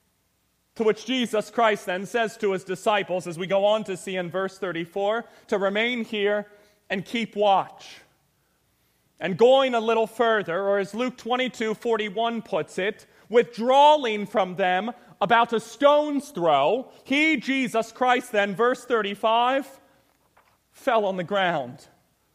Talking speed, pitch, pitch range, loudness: 140 wpm, 215 Hz, 195-235 Hz, -24 LUFS